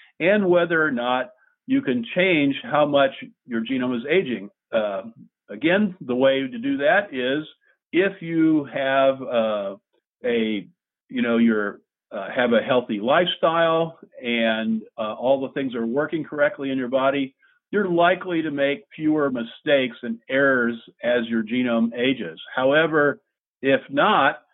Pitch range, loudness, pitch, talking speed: 120-170 Hz, -22 LUFS, 140 Hz, 145 wpm